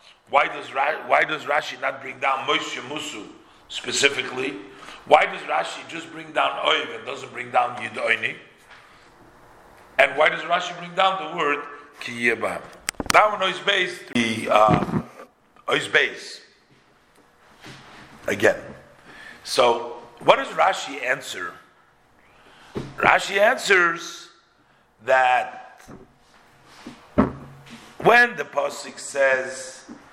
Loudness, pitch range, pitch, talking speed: -21 LUFS, 130-180 Hz, 145 Hz, 105 wpm